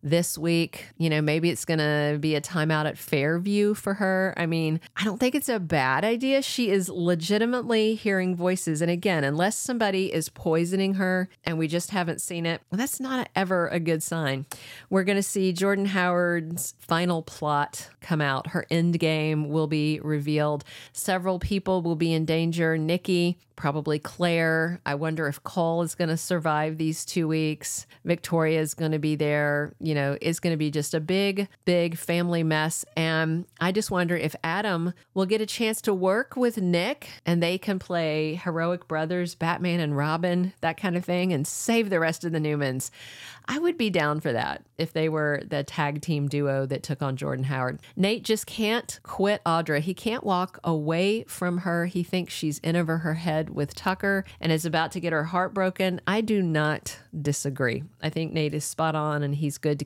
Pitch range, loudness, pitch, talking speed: 155-185 Hz, -26 LUFS, 165 Hz, 190 wpm